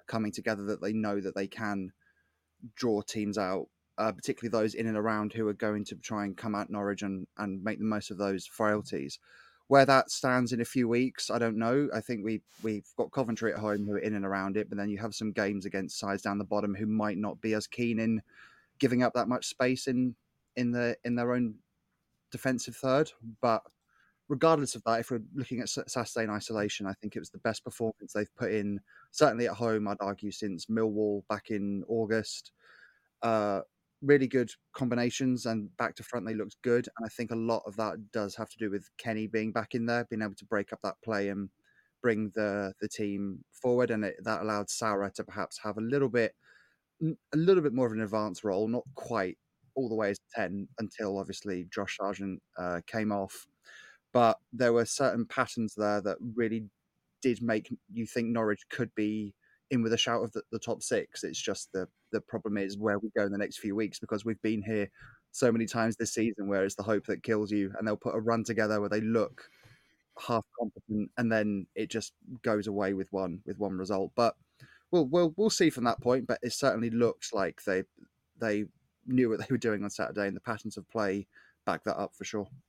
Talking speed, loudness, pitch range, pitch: 220 wpm, -32 LUFS, 105-120 Hz, 110 Hz